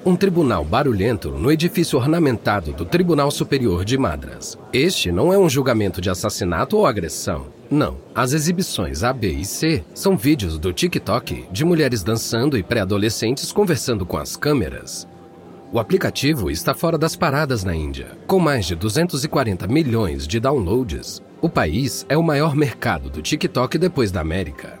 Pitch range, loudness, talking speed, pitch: 95-160 Hz, -20 LUFS, 160 wpm, 125 Hz